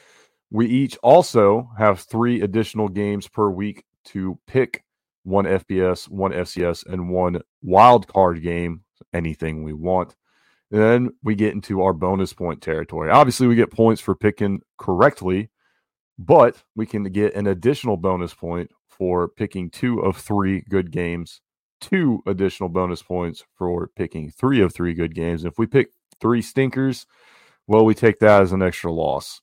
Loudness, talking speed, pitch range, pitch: -20 LUFS, 160 wpm, 90-110 Hz, 95 Hz